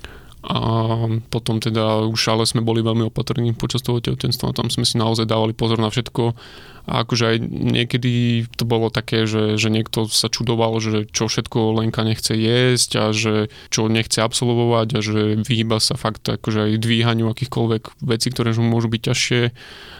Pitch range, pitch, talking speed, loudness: 110-120 Hz, 115 Hz, 175 wpm, -19 LUFS